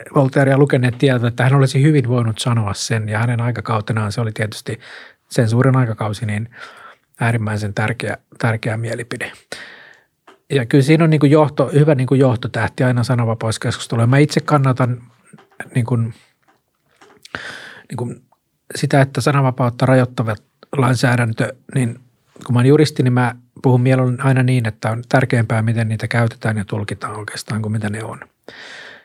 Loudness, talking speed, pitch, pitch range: -17 LUFS, 155 wpm, 125 Hz, 115-135 Hz